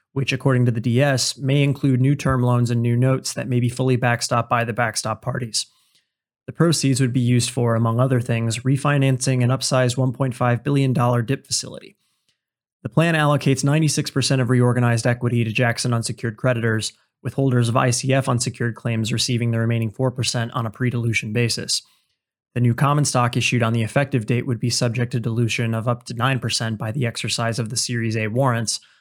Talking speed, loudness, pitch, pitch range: 185 wpm, -20 LUFS, 125 Hz, 120-130 Hz